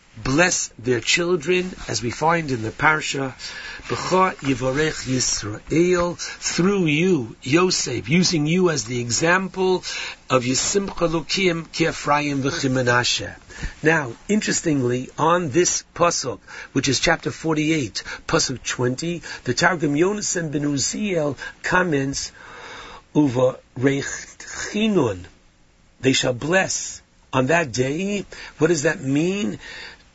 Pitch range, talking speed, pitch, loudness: 130-175 Hz, 105 wpm, 150 Hz, -21 LUFS